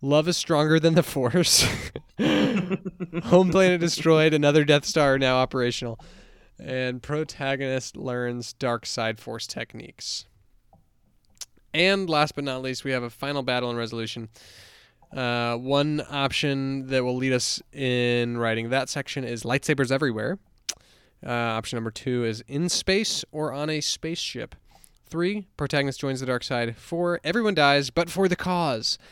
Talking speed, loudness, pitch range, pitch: 150 wpm, -24 LUFS, 120-155 Hz, 135 Hz